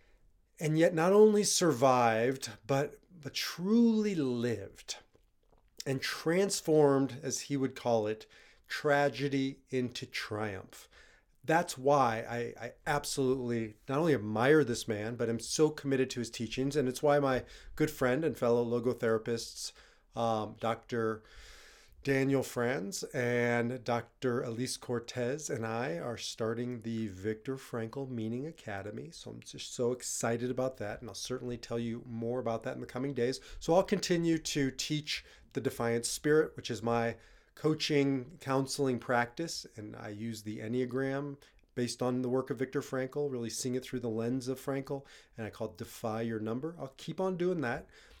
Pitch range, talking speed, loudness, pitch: 115-140 Hz, 160 wpm, -33 LUFS, 125 Hz